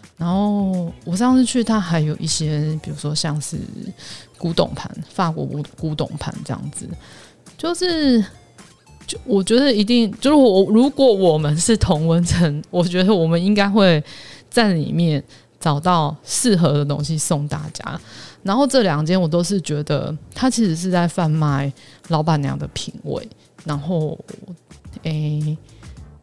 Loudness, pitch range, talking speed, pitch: -19 LUFS, 150-205 Hz, 215 characters per minute, 170 Hz